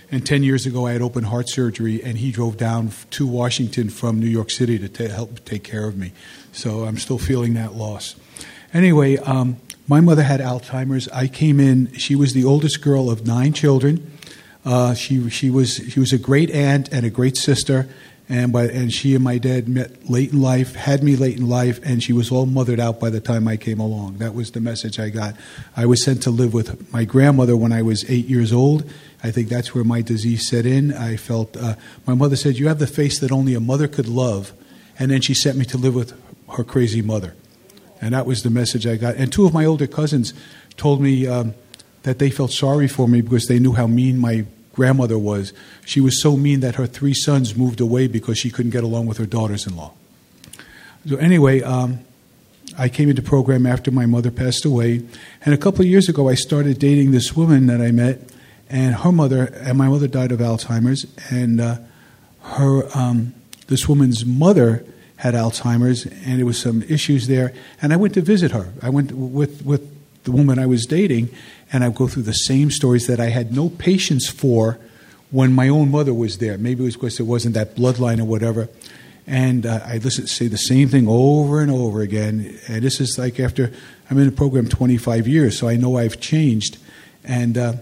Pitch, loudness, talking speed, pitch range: 125 Hz, -18 LUFS, 220 wpm, 115-135 Hz